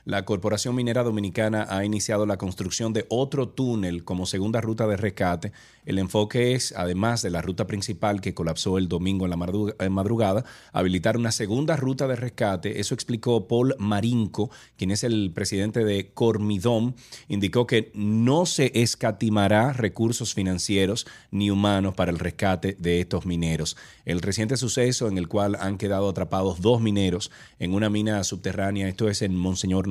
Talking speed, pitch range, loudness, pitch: 165 wpm, 95-115 Hz, -25 LUFS, 105 Hz